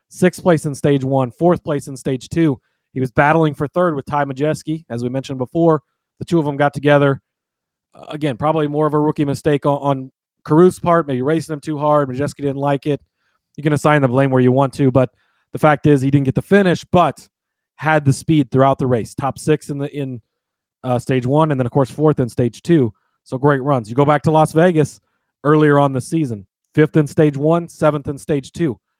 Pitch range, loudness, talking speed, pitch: 135-155 Hz, -16 LUFS, 230 wpm, 145 Hz